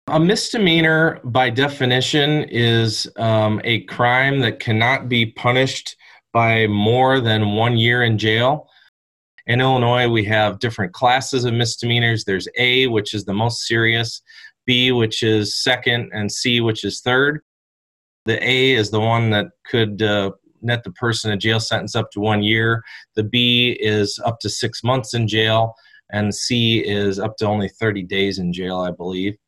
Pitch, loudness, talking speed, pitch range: 115 Hz, -18 LUFS, 165 wpm, 105-125 Hz